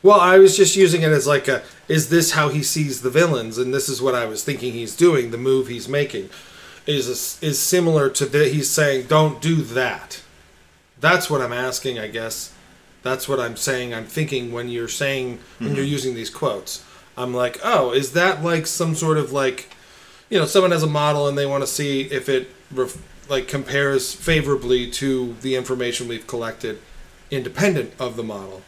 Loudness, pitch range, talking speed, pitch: -20 LUFS, 125-150 Hz, 195 wpm, 135 Hz